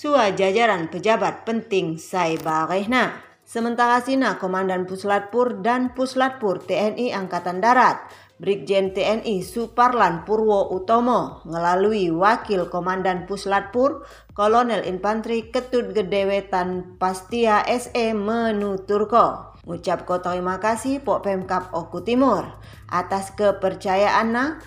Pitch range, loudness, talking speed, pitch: 185-235 Hz, -21 LUFS, 95 wpm, 205 Hz